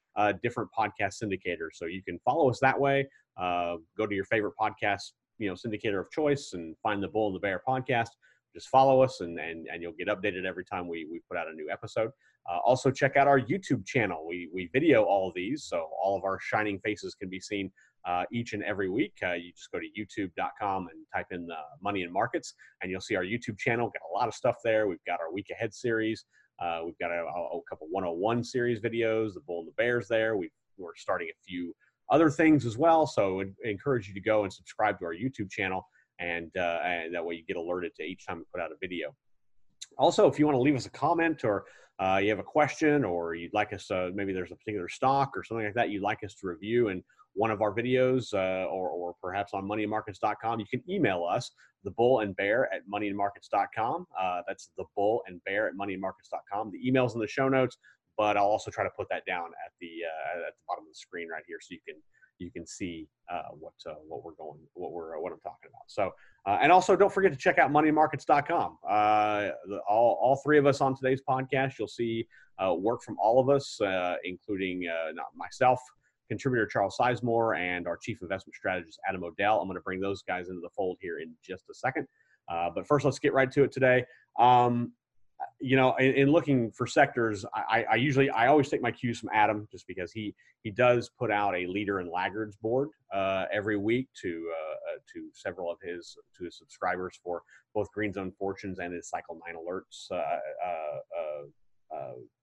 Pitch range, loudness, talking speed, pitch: 95-130 Hz, -29 LUFS, 225 wpm, 110 Hz